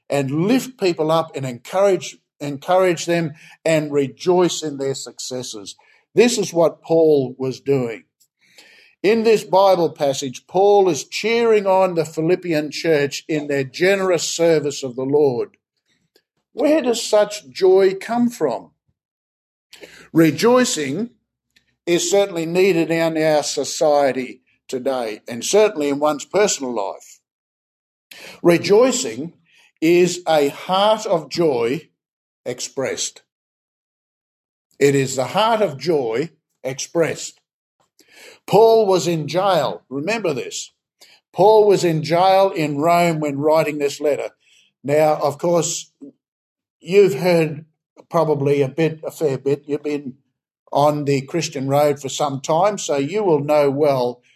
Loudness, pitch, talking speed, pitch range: -18 LUFS, 160 Hz, 125 wpm, 140-190 Hz